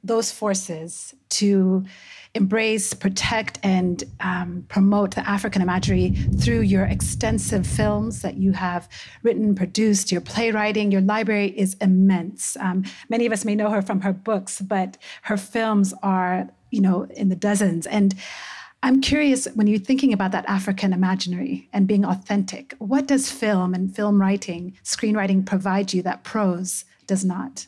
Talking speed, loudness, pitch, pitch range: 155 wpm, -22 LUFS, 195 Hz, 185-210 Hz